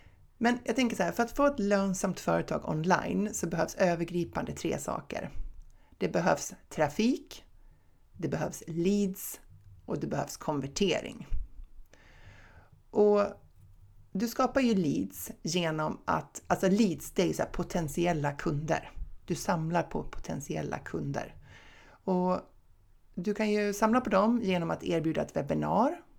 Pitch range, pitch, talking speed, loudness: 145-210 Hz, 180 Hz, 135 wpm, -31 LUFS